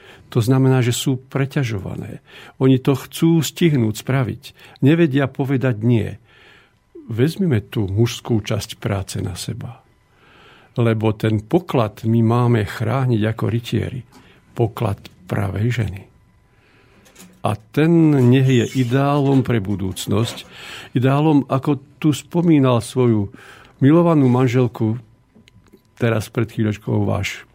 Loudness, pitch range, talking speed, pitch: -19 LUFS, 110-135 Hz, 105 wpm, 120 Hz